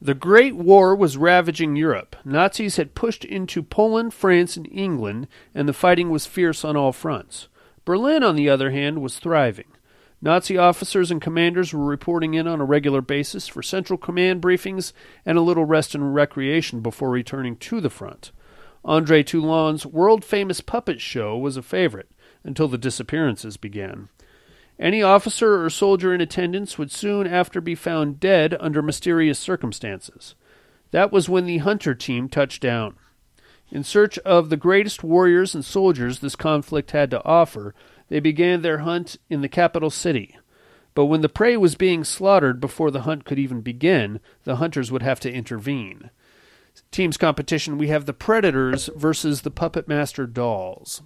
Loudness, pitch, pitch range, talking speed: -20 LUFS, 160 Hz, 140-180 Hz, 165 wpm